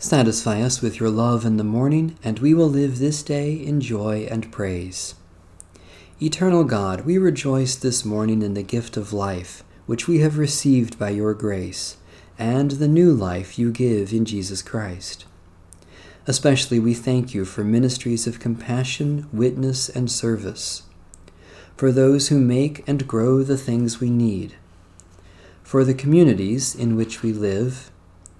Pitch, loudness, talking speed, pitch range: 115 Hz, -21 LUFS, 155 wpm, 95-130 Hz